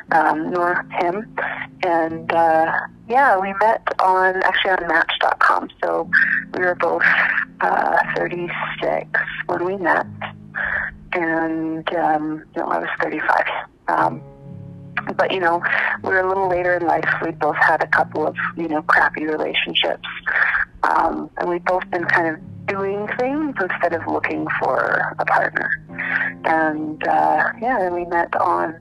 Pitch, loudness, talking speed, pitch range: 175 Hz, -19 LUFS, 150 wpm, 160-185 Hz